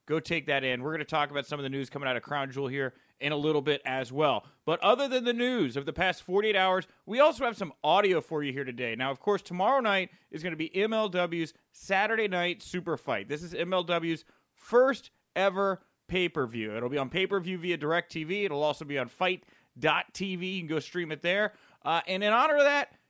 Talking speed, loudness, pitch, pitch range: 235 wpm, -29 LUFS, 175 Hz, 145-195 Hz